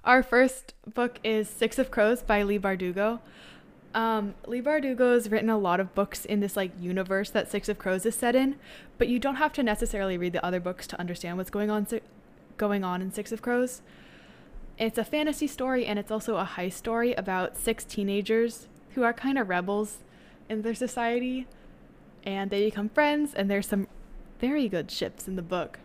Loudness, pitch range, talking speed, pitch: -28 LUFS, 195-245 Hz, 195 wpm, 220 Hz